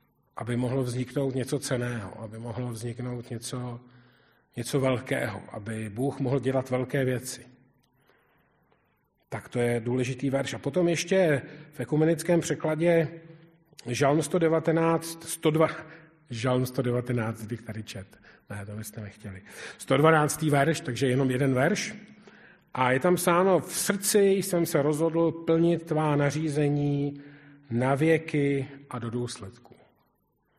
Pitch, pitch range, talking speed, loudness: 140 Hz, 125-160 Hz, 125 wpm, -27 LUFS